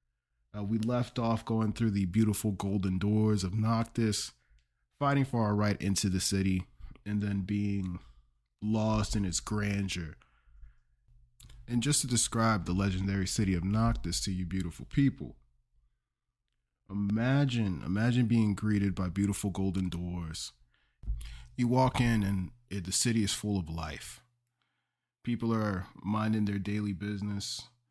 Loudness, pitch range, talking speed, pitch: -31 LUFS, 95-115 Hz, 140 wpm, 105 Hz